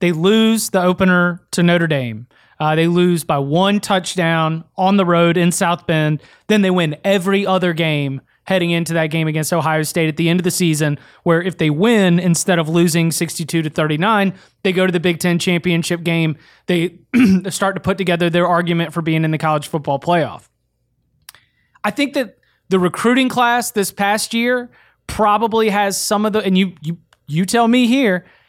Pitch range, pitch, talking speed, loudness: 165-195 Hz, 175 Hz, 190 wpm, -16 LUFS